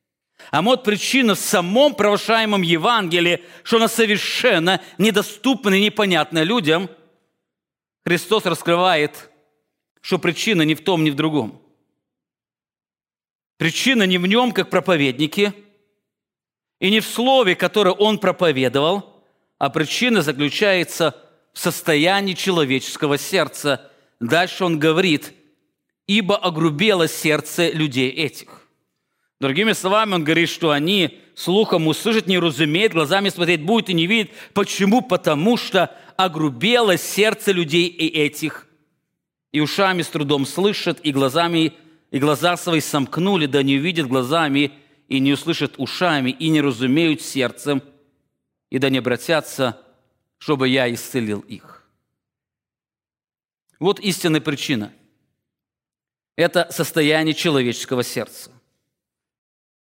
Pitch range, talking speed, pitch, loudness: 145-195 Hz, 115 wpm, 165 Hz, -18 LUFS